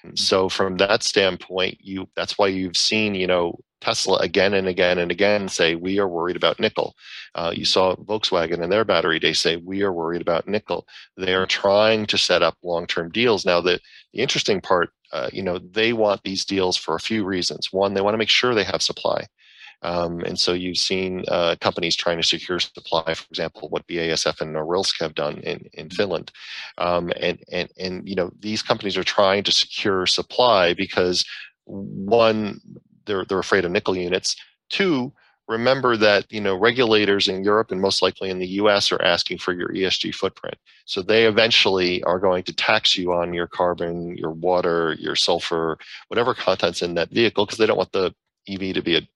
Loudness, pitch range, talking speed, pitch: -21 LUFS, 90-100 Hz, 200 wpm, 95 Hz